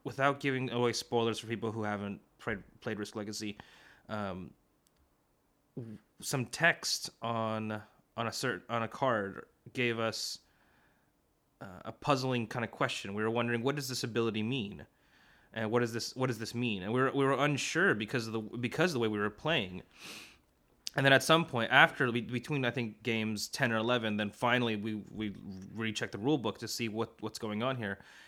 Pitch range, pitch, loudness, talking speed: 110-125 Hz, 115 Hz, -33 LUFS, 190 wpm